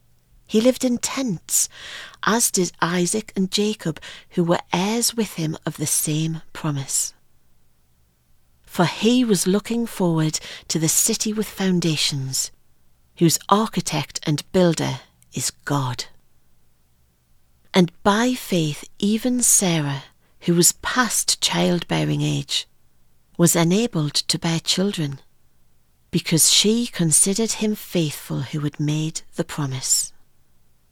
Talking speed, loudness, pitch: 115 wpm, -20 LUFS, 160 Hz